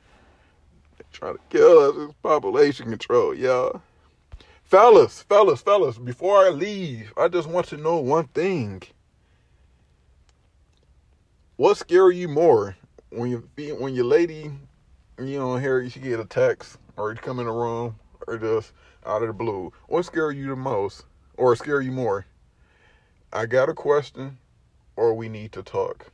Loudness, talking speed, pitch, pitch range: -21 LUFS, 155 wpm, 130 Hz, 110-180 Hz